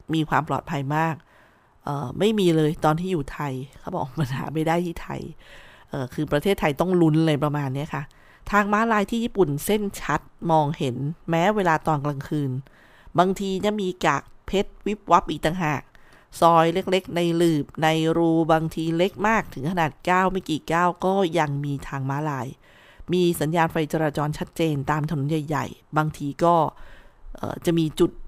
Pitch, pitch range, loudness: 160 Hz, 145-175 Hz, -23 LUFS